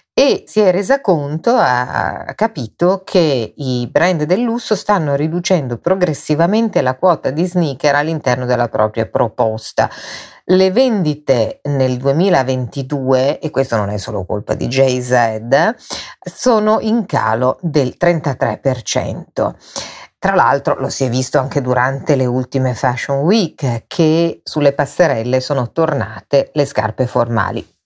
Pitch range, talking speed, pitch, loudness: 125-175 Hz, 130 wpm, 140 Hz, -16 LUFS